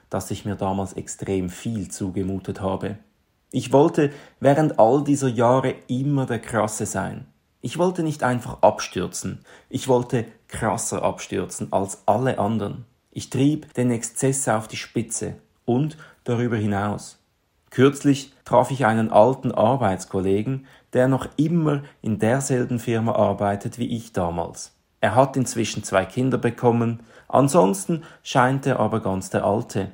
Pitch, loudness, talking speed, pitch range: 120 Hz, -22 LUFS, 140 wpm, 105-135 Hz